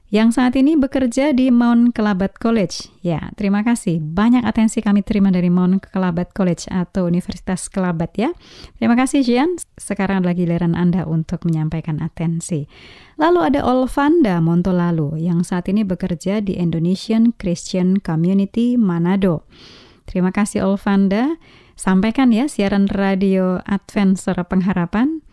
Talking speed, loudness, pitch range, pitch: 135 wpm, -18 LUFS, 175-230 Hz, 195 Hz